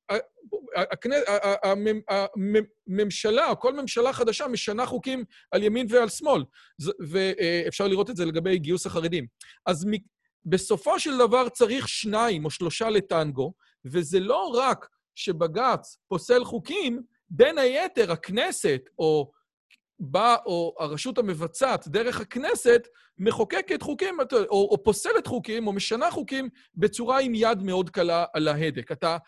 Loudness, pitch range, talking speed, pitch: -25 LUFS, 180-250 Hz, 125 wpm, 215 Hz